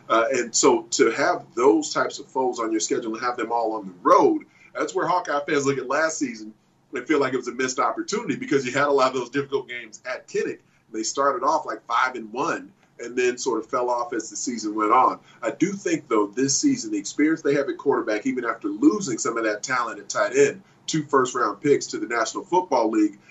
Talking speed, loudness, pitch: 245 wpm, -23 LUFS, 160 Hz